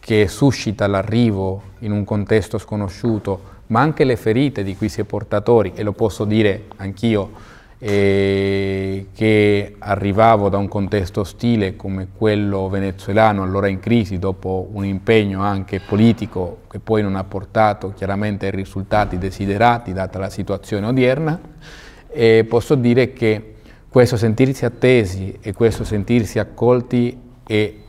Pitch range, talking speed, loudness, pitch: 100-115 Hz, 140 wpm, -18 LUFS, 105 Hz